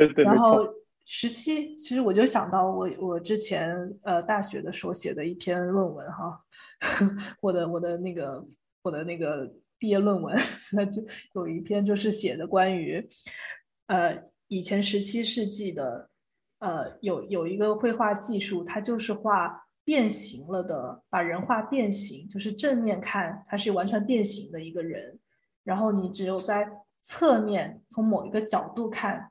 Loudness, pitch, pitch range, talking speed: -28 LUFS, 205 Hz, 185-215 Hz, 230 characters per minute